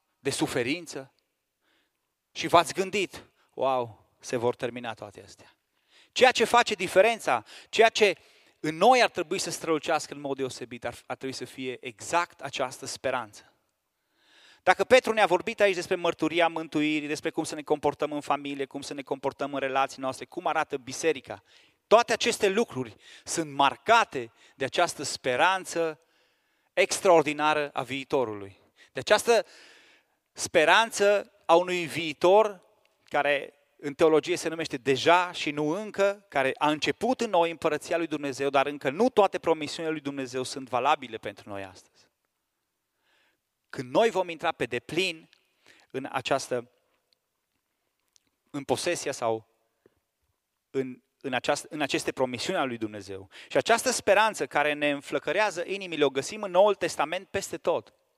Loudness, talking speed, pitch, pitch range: -26 LUFS, 140 wpm, 155 Hz, 135-180 Hz